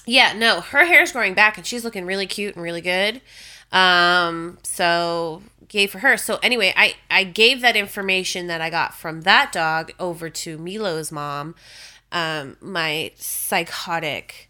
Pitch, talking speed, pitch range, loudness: 180 Hz, 160 wpm, 165-205 Hz, -19 LUFS